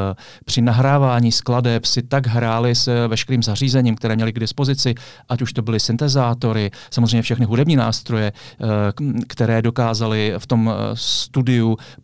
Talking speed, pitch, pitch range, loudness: 135 wpm, 120 Hz, 115-125 Hz, -18 LUFS